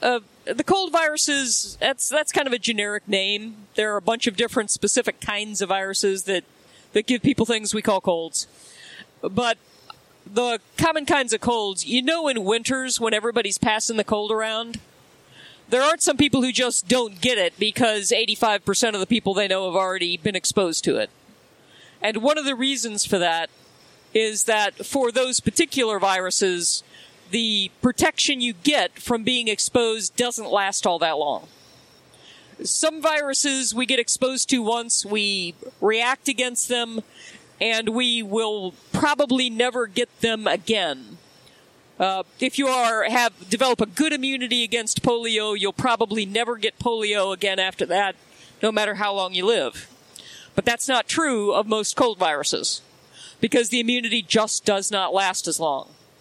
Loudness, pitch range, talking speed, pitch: -22 LUFS, 205-250 Hz, 165 wpm, 225 Hz